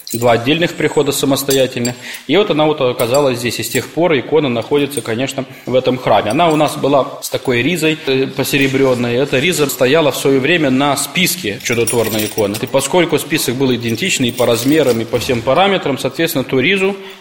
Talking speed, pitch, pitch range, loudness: 185 wpm, 135 Hz, 125-150 Hz, -14 LUFS